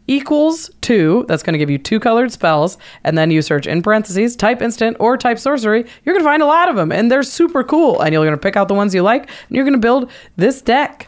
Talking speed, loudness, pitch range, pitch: 270 wpm, -14 LUFS, 185-275 Hz, 235 Hz